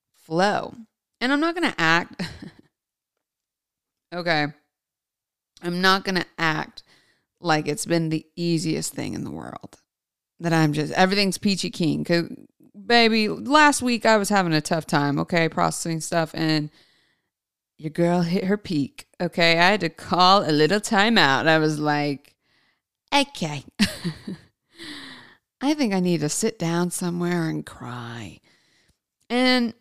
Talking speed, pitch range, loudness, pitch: 145 wpm, 155-210 Hz, -22 LUFS, 175 Hz